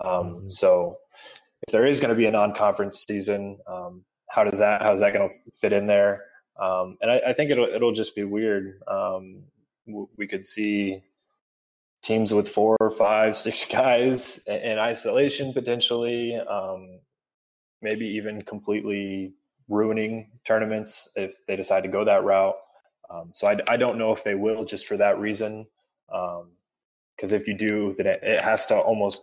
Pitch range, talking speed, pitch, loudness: 95-110 Hz, 170 wpm, 105 Hz, -24 LUFS